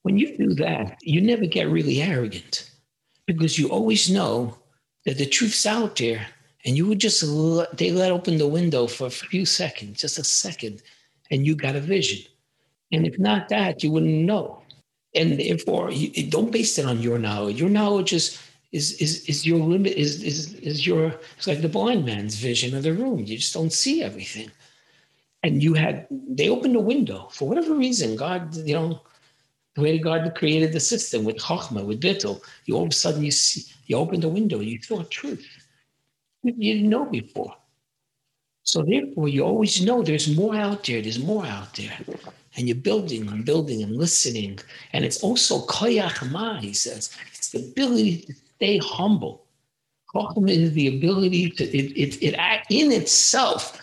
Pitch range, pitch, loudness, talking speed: 140-195 Hz, 160 Hz, -22 LUFS, 185 wpm